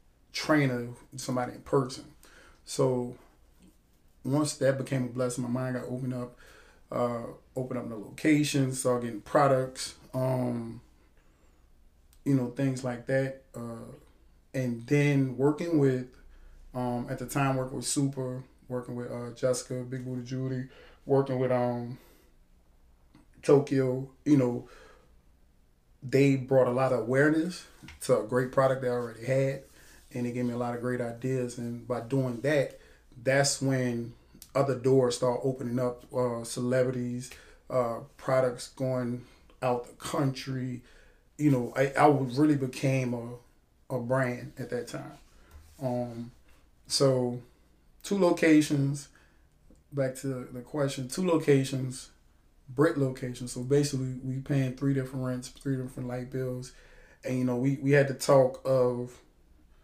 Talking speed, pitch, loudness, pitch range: 140 wpm, 125 Hz, -29 LUFS, 120-135 Hz